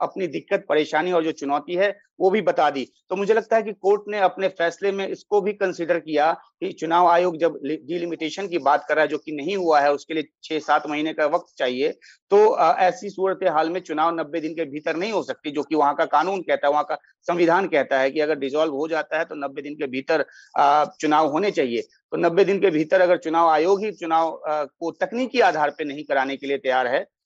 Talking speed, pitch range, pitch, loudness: 240 wpm, 150-190 Hz, 165 Hz, -22 LUFS